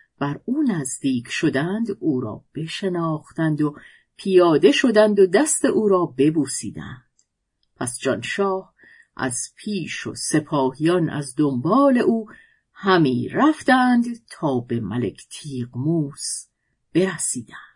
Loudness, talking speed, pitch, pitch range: -21 LUFS, 105 wpm, 160 Hz, 140-210 Hz